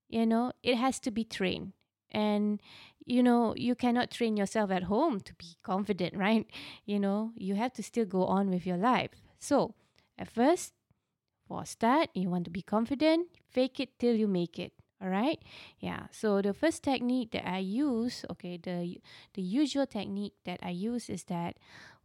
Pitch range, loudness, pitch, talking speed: 190-250 Hz, -32 LUFS, 215 Hz, 185 wpm